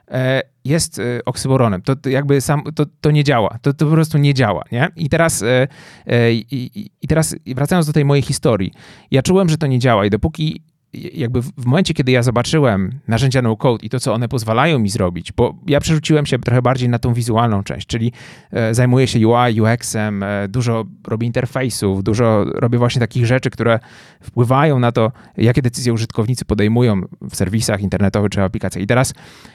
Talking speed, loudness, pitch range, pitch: 180 wpm, -16 LUFS, 115-140 Hz, 125 Hz